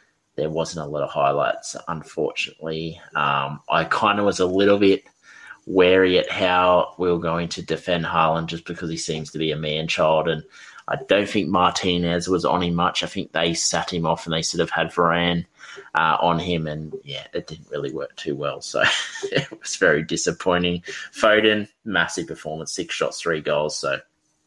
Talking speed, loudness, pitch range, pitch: 190 wpm, -22 LUFS, 80-90 Hz, 85 Hz